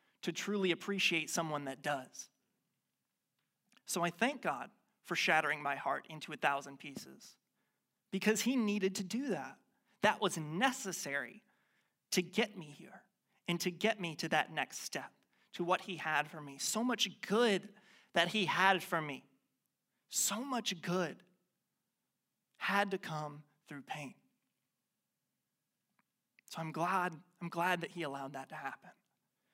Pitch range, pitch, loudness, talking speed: 160-210 Hz, 185 Hz, -36 LUFS, 145 wpm